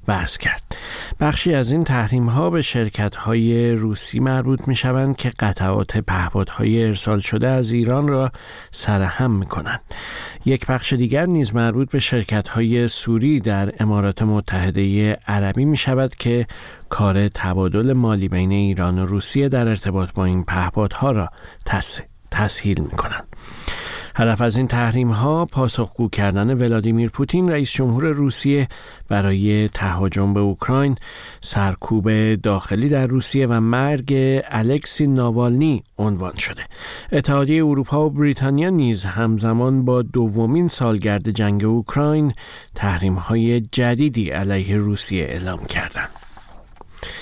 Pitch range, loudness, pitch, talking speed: 100-130 Hz, -19 LUFS, 115 Hz, 130 wpm